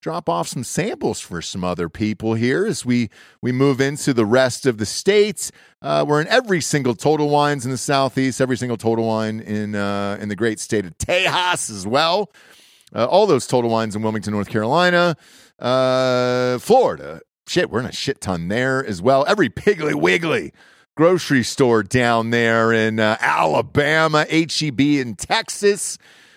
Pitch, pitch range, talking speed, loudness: 125 Hz, 110-150 Hz, 175 wpm, -19 LUFS